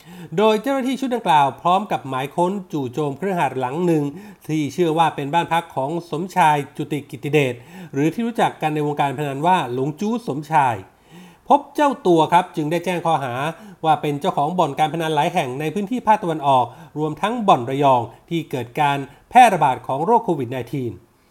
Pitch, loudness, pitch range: 160 Hz, -20 LUFS, 145-180 Hz